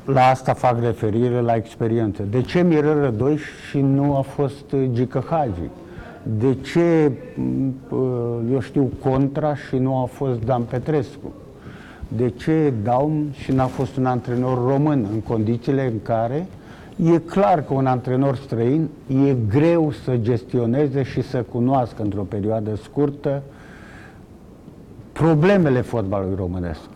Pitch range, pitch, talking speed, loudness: 120-145 Hz, 130 Hz, 130 wpm, -21 LUFS